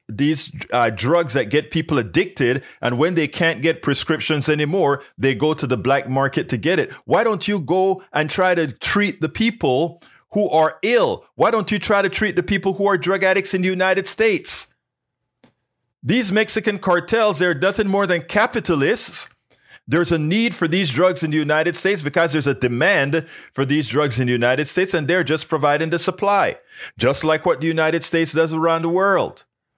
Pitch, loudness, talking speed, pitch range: 165 Hz, -19 LUFS, 195 wpm, 150-195 Hz